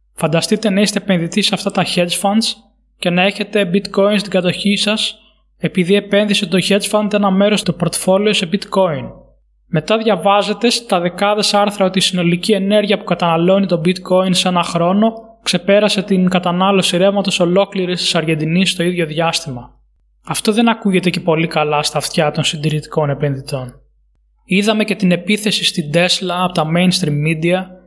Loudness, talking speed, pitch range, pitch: -15 LUFS, 160 wpm, 170-205 Hz, 185 Hz